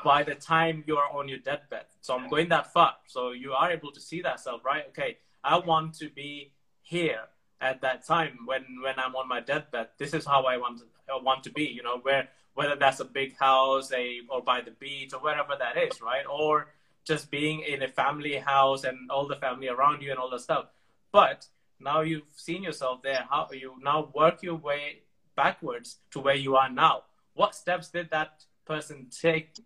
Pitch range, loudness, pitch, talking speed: 130-155 Hz, -28 LUFS, 140 Hz, 215 wpm